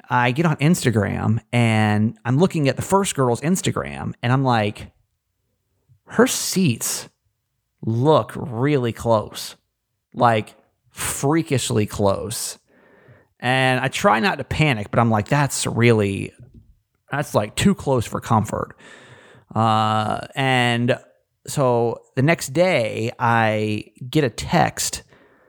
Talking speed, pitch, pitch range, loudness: 120 wpm, 120 Hz, 110-135 Hz, -20 LUFS